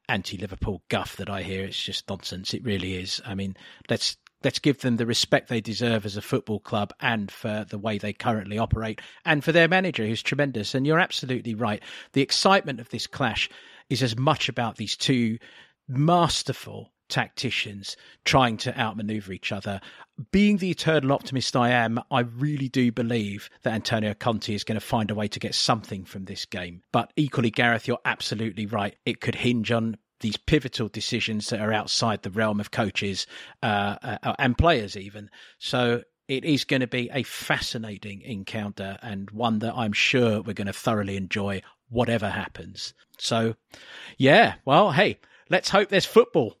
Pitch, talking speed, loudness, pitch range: 115 Hz, 180 wpm, -25 LUFS, 105-130 Hz